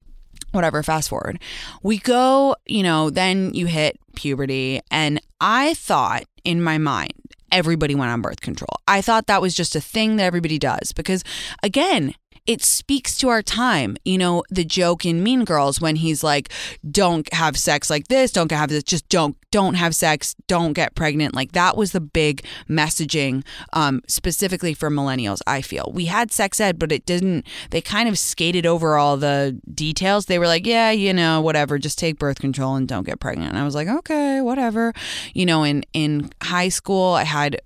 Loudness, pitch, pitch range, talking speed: -20 LUFS, 165 Hz, 150-190 Hz, 195 wpm